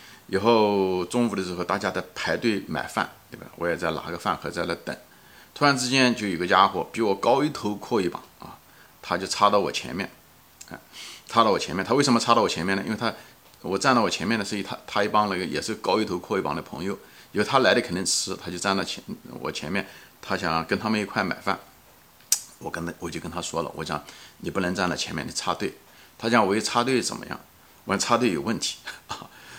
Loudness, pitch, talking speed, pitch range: -25 LUFS, 105 Hz, 315 characters per minute, 95-115 Hz